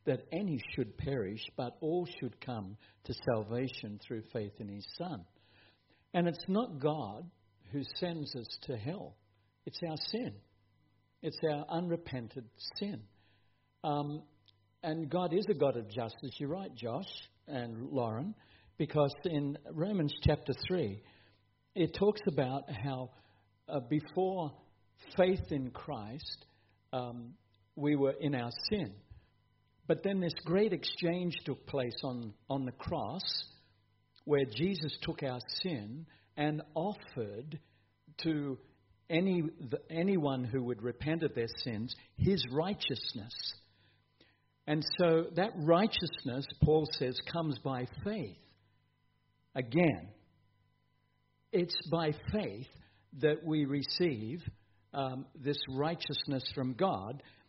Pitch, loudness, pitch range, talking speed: 135 Hz, -36 LUFS, 110-160 Hz, 120 wpm